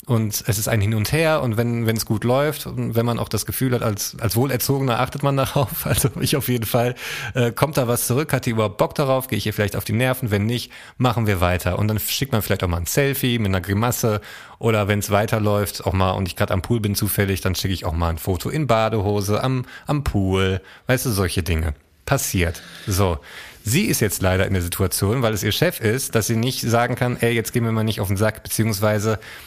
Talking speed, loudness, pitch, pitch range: 250 wpm, -21 LUFS, 110 Hz, 100-125 Hz